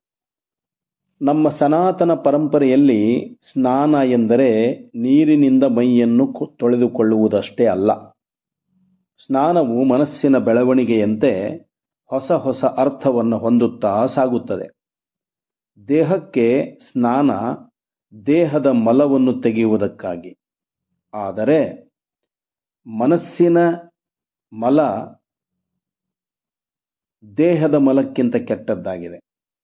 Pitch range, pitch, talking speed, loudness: 120-170 Hz, 140 Hz, 55 wpm, -17 LUFS